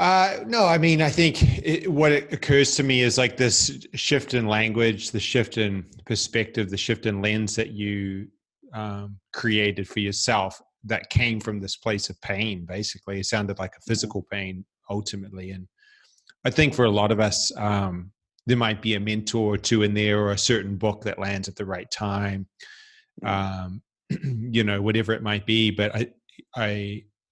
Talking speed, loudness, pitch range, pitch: 185 wpm, -24 LUFS, 100-115 Hz, 105 Hz